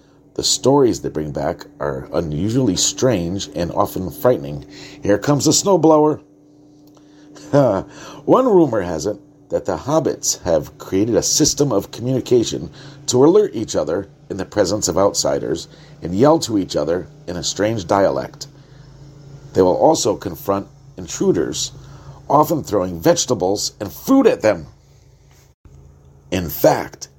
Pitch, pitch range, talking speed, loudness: 140 Hz, 100-150 Hz, 130 wpm, -18 LUFS